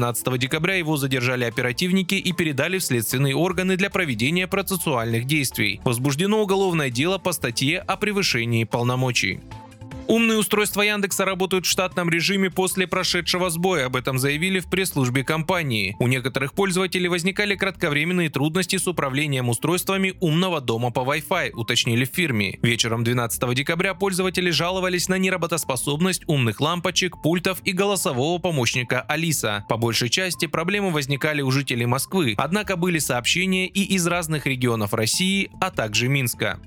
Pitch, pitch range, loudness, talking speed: 165 Hz, 130-185 Hz, -22 LUFS, 140 wpm